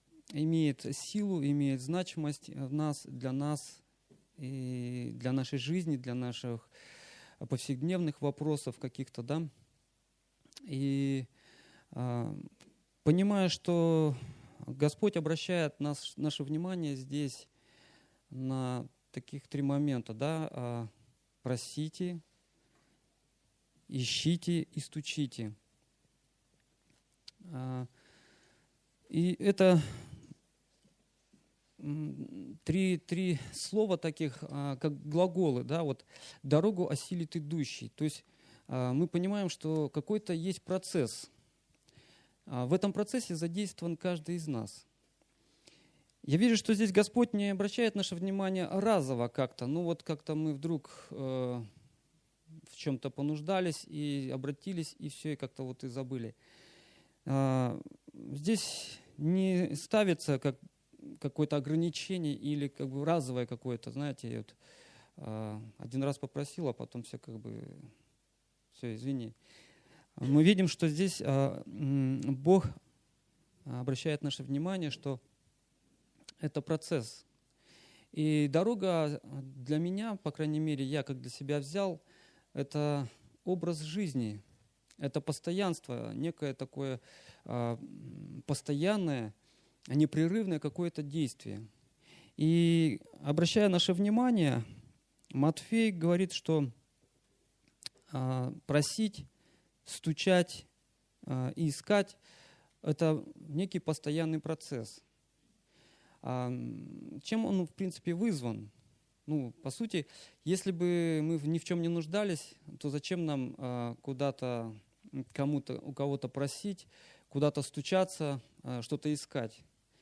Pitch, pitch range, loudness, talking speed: 150 Hz, 135-170 Hz, -34 LUFS, 100 wpm